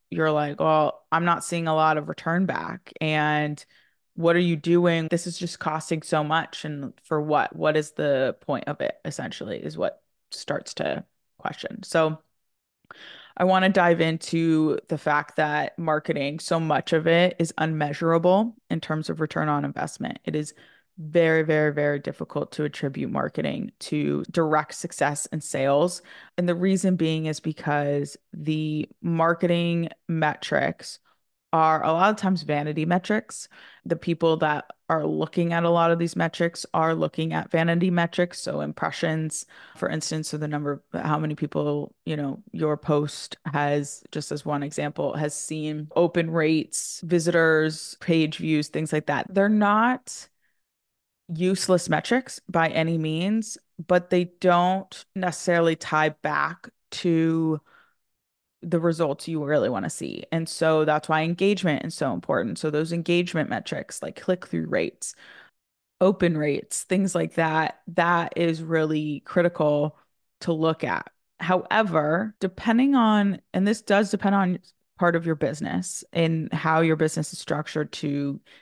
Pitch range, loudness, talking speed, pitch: 150-175 Hz, -25 LUFS, 155 wpm, 160 Hz